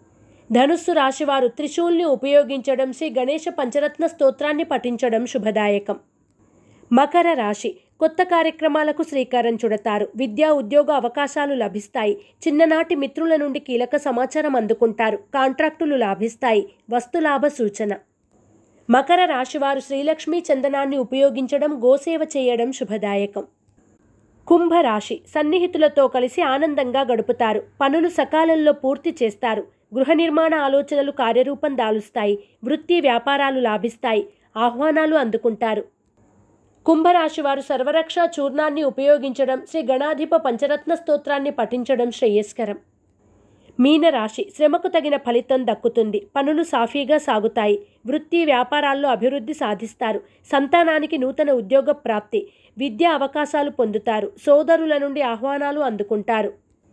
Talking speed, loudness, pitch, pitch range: 95 wpm, -20 LUFS, 275 Hz, 235-305 Hz